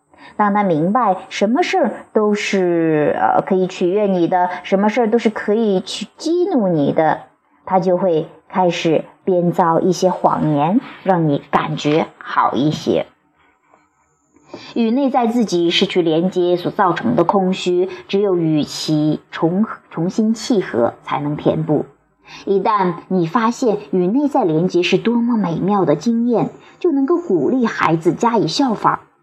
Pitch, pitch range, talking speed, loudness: 190 Hz, 175-225 Hz, 215 characters per minute, -17 LUFS